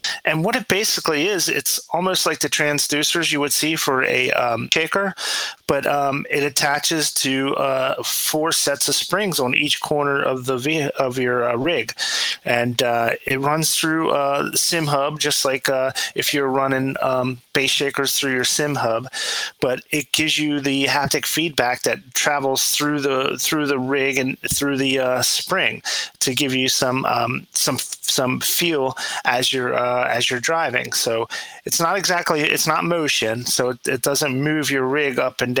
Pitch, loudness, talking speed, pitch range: 140 Hz, -19 LUFS, 185 wpm, 130-150 Hz